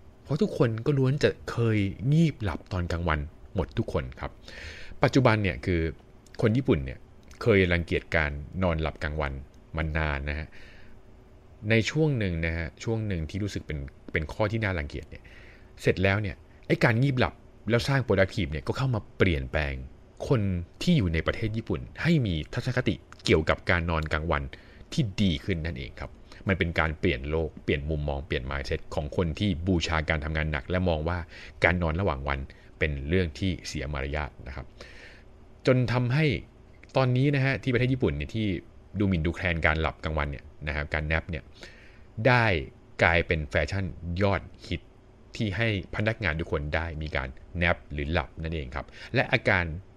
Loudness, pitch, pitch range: -28 LUFS, 90 Hz, 80-110 Hz